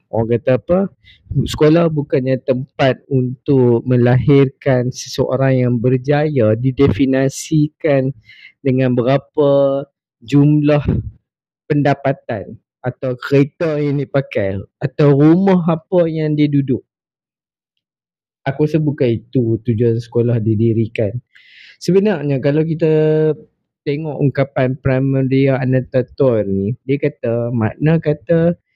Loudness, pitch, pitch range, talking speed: -16 LUFS, 135 Hz, 125-150 Hz, 95 wpm